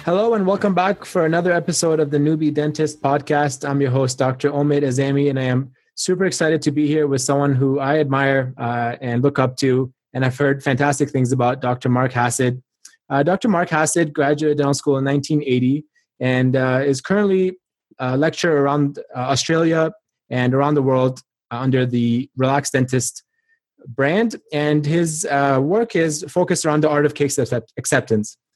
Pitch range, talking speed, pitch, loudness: 130-155 Hz, 180 wpm, 140 Hz, -19 LUFS